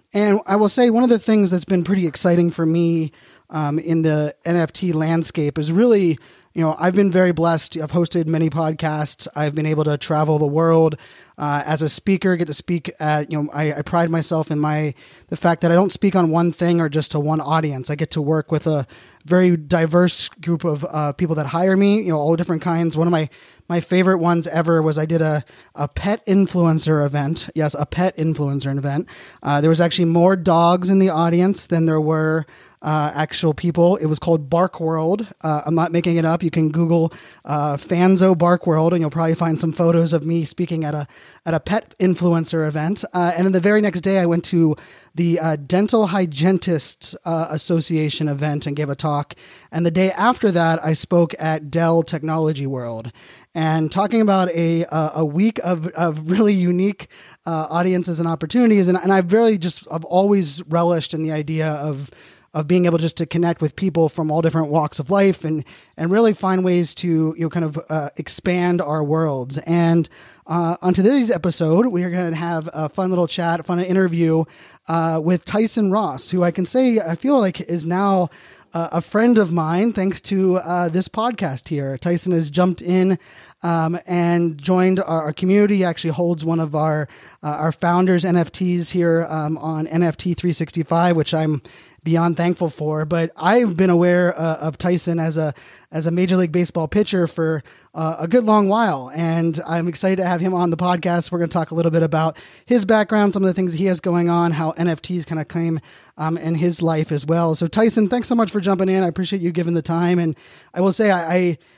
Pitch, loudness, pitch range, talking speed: 170 Hz, -19 LUFS, 160-180 Hz, 210 wpm